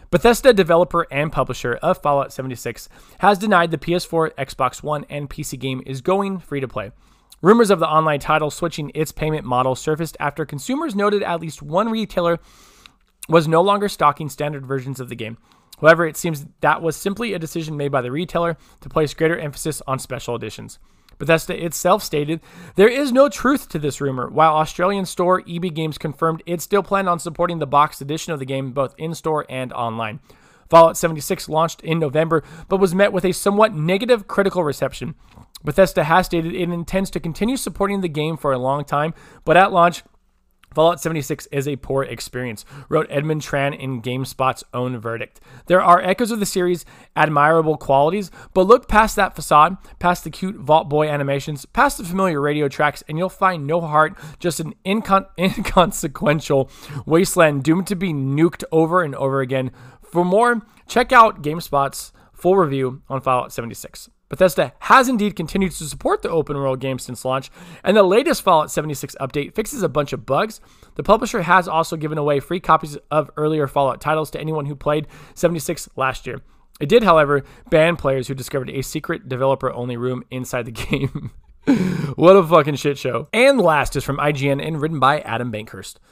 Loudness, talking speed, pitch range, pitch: -19 LUFS, 185 wpm, 140-180 Hz, 155 Hz